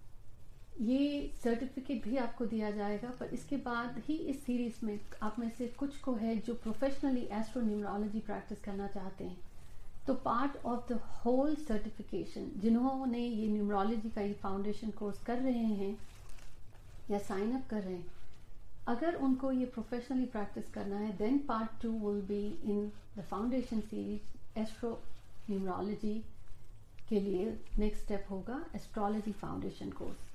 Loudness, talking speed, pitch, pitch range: -38 LUFS, 145 wpm, 215 Hz, 200-245 Hz